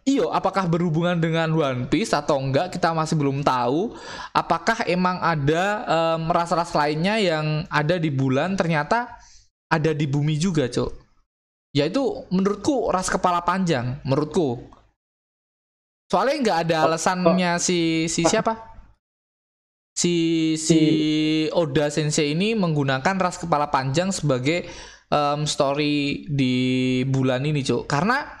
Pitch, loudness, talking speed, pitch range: 160 Hz, -22 LUFS, 125 wpm, 145-180 Hz